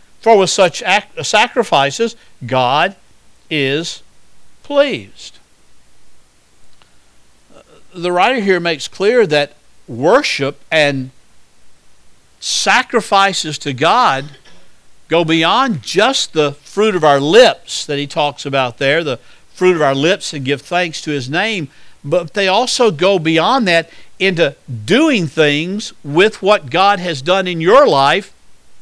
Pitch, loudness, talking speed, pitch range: 170 Hz, -14 LUFS, 125 wpm, 145-200 Hz